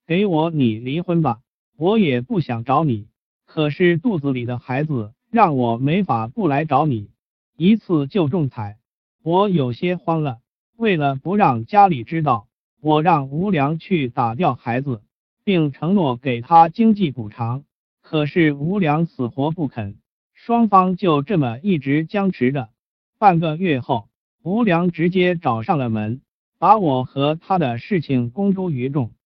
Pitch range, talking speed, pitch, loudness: 125-180 Hz, 215 characters per minute, 150 Hz, -19 LUFS